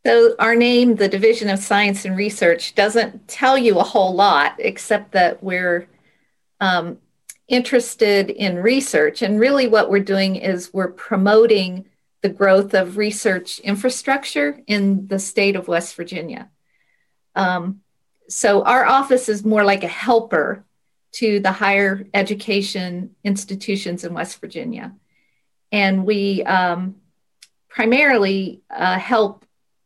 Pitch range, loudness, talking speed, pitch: 190-230 Hz, -18 LUFS, 130 wpm, 200 Hz